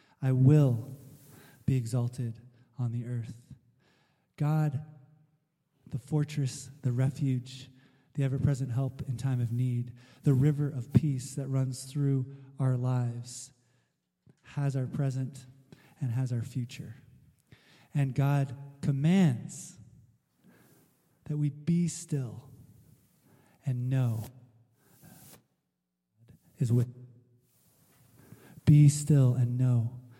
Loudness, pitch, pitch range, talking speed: -30 LUFS, 135 Hz, 125-145 Hz, 105 wpm